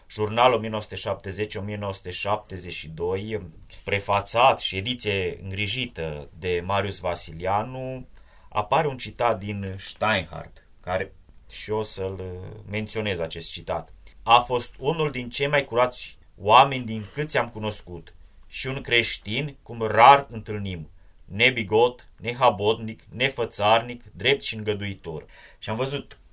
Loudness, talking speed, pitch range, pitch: -24 LUFS, 110 wpm, 95-120 Hz, 105 Hz